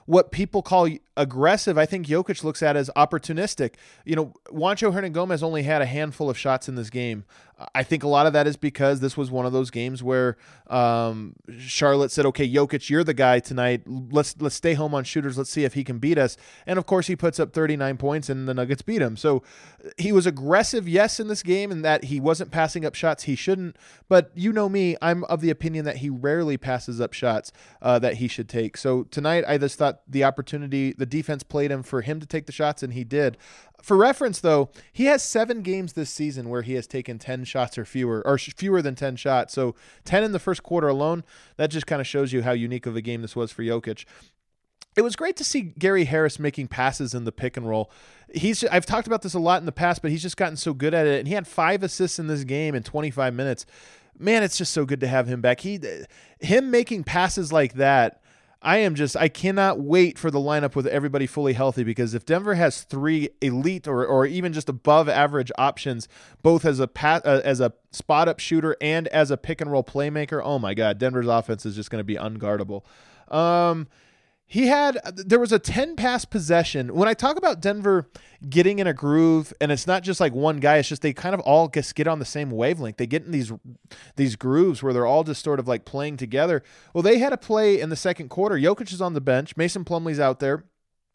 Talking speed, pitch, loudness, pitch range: 230 wpm, 150 Hz, -23 LUFS, 135-175 Hz